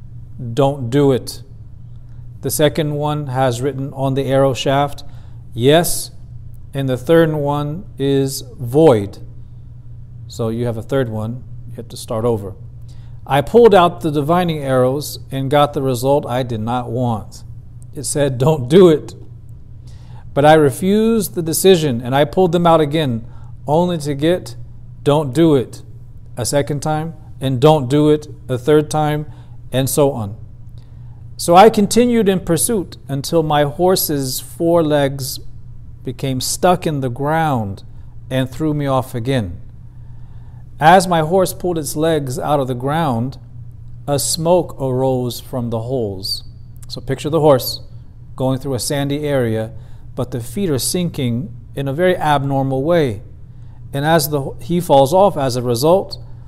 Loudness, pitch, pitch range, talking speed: -16 LUFS, 130 Hz, 120-150 Hz, 150 wpm